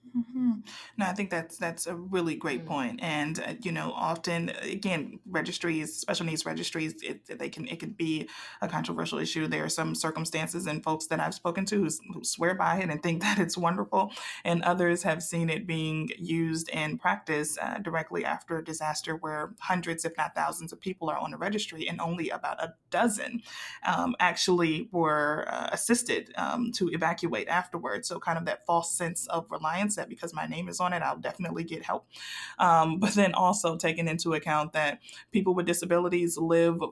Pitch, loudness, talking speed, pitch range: 170 Hz, -30 LUFS, 195 wpm, 160-180 Hz